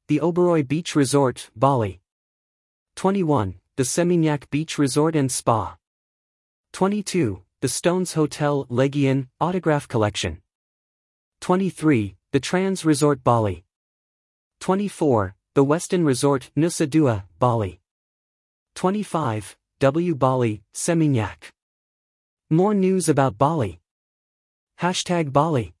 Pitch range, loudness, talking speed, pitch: 105-165 Hz, -22 LUFS, 95 wpm, 140 Hz